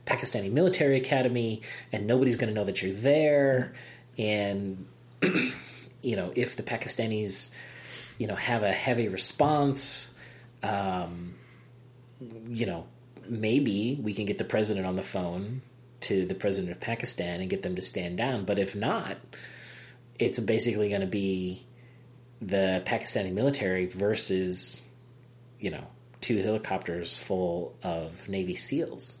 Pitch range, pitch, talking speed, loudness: 95-125 Hz, 110 Hz, 135 wpm, -29 LUFS